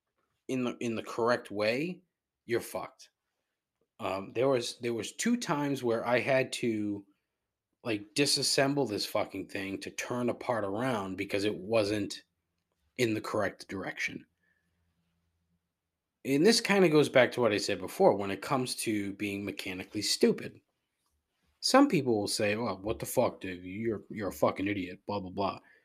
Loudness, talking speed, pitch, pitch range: -30 LUFS, 165 wpm, 105 Hz, 95-130 Hz